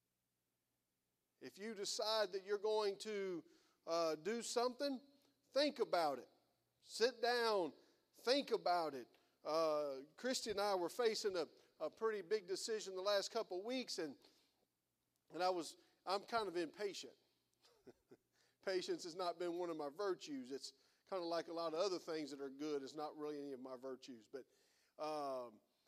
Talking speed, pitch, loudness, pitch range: 165 wpm, 195 Hz, -43 LUFS, 150-245 Hz